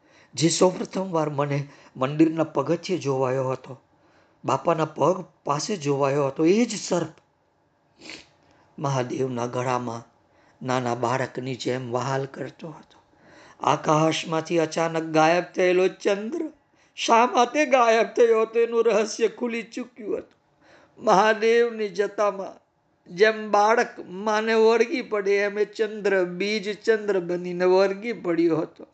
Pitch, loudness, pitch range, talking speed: 180 Hz, -23 LUFS, 145-220 Hz, 115 wpm